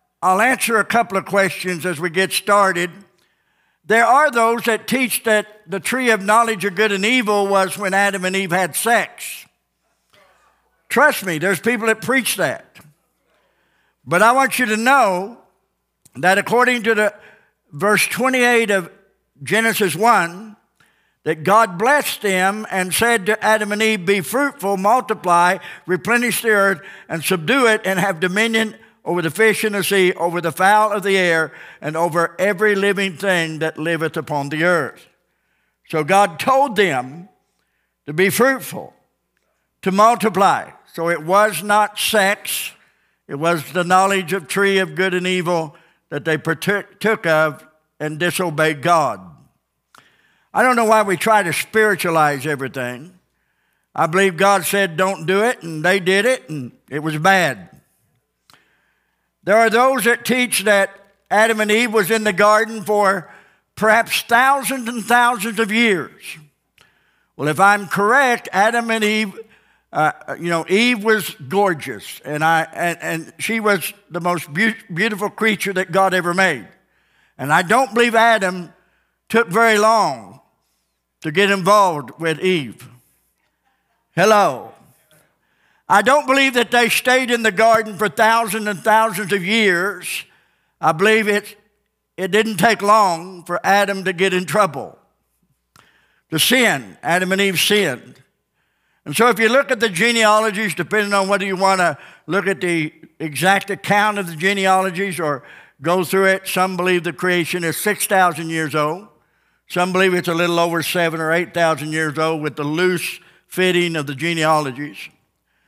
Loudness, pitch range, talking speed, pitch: -17 LUFS, 170-220 Hz, 155 wpm, 195 Hz